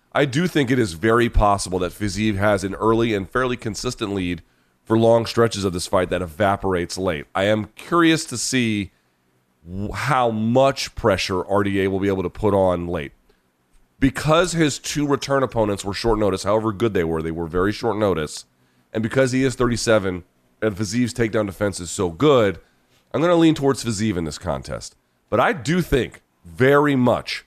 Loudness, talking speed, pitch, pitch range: -20 LUFS, 190 wpm, 110 Hz, 90-125 Hz